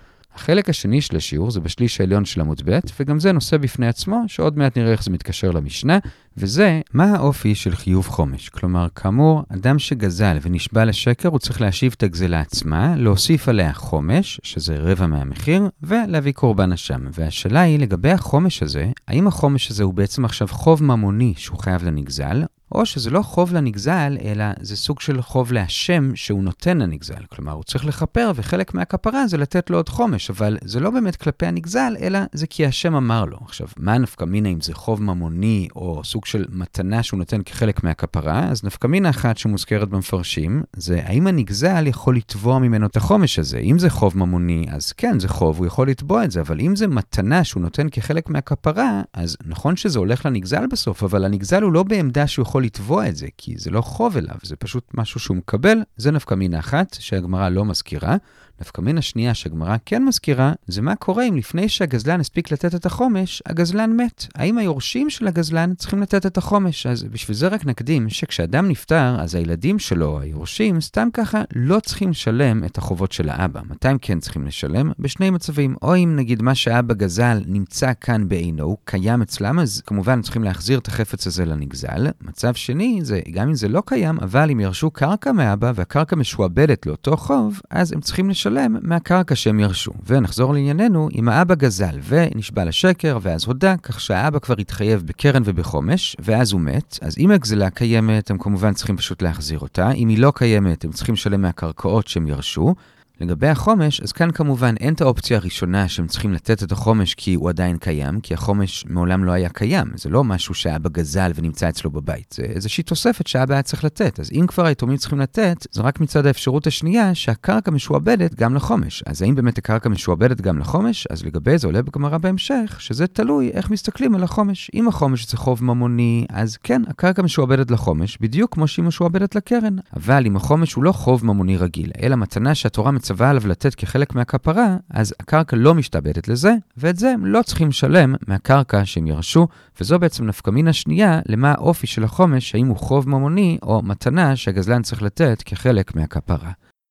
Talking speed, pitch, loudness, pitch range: 175 wpm, 120 Hz, -19 LUFS, 95-160 Hz